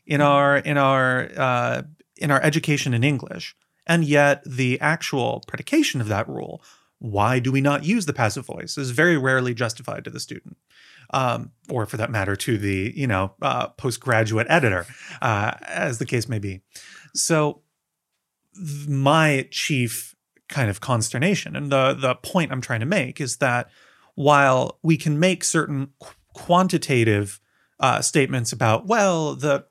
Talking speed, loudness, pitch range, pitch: 160 wpm, -21 LUFS, 120-150 Hz, 135 Hz